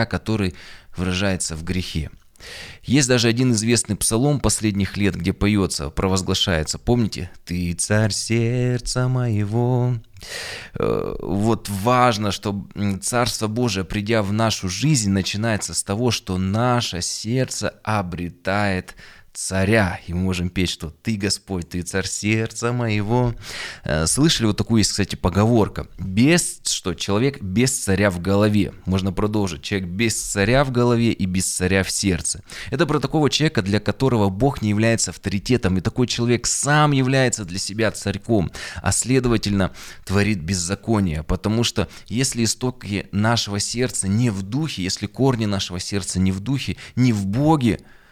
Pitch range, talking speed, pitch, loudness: 95-120 Hz, 140 wpm, 105 Hz, -21 LUFS